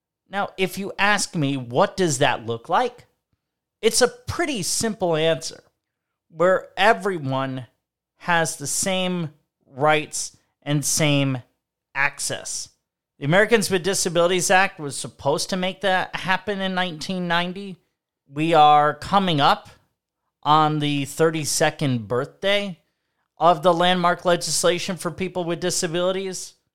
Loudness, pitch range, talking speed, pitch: -21 LUFS, 150-190 Hz, 120 wpm, 175 Hz